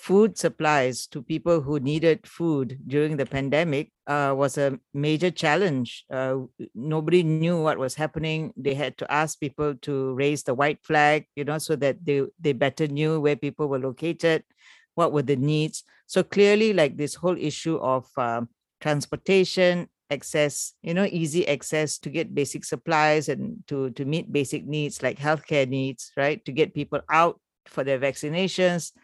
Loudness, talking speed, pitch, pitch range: -25 LUFS, 170 wpm, 150 Hz, 140-165 Hz